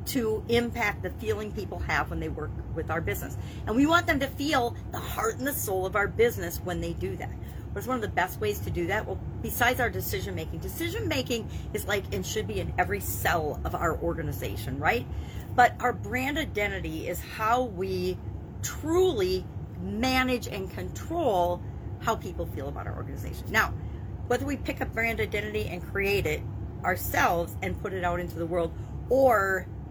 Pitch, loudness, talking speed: 110 Hz, -29 LUFS, 190 wpm